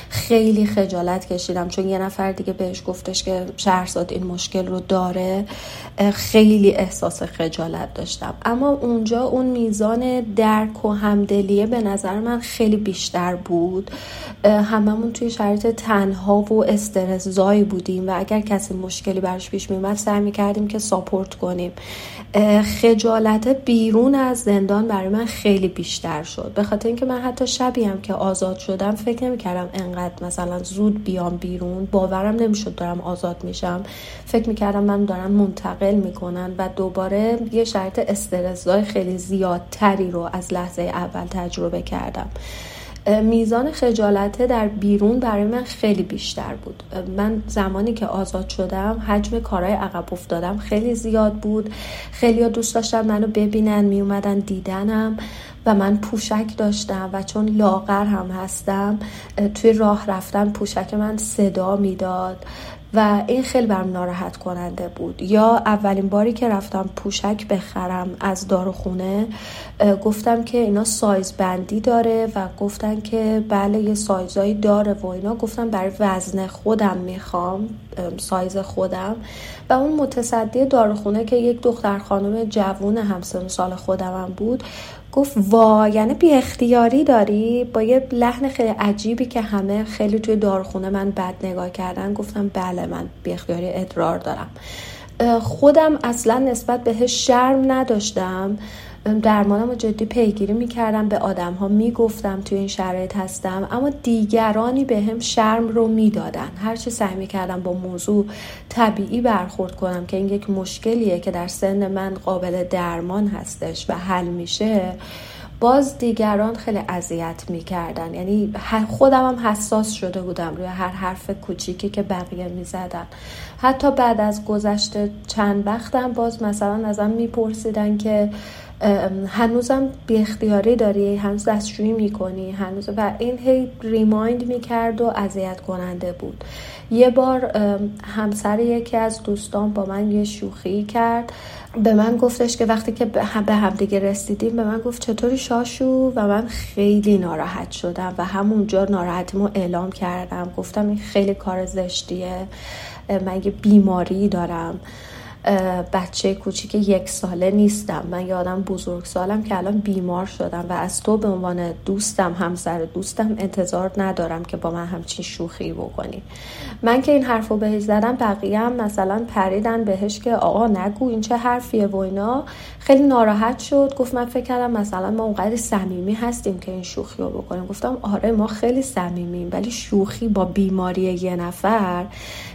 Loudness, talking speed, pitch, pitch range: -20 LUFS, 145 wpm, 205 Hz, 185-225 Hz